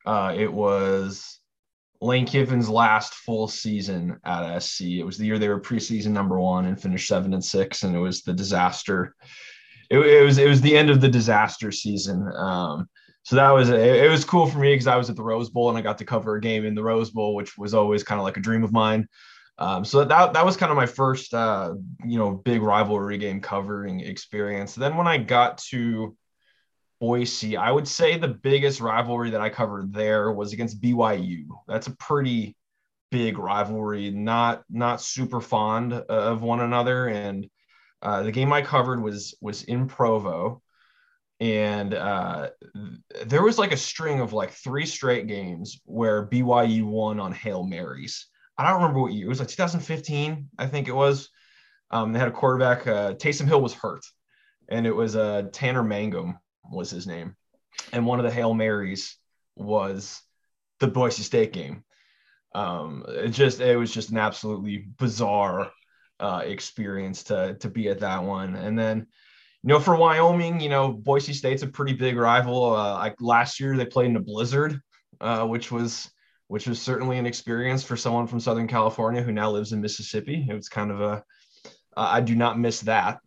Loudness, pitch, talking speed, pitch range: -23 LUFS, 115 Hz, 190 wpm, 105-130 Hz